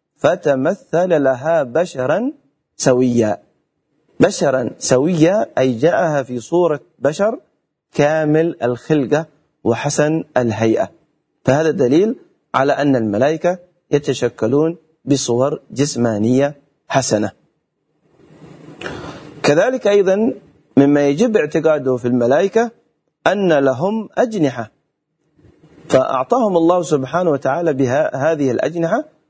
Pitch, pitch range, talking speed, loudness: 150 Hz, 130-165 Hz, 85 wpm, -16 LUFS